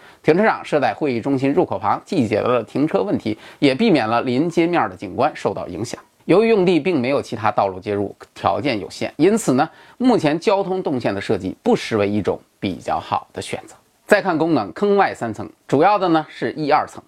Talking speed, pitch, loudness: 315 characters per minute, 150 Hz, -19 LUFS